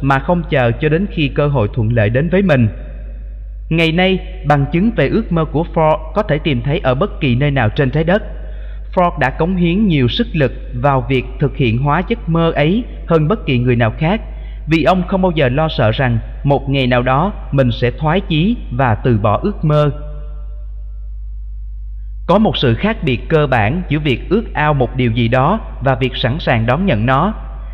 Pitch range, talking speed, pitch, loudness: 120-165 Hz, 210 wpm, 140 Hz, -15 LUFS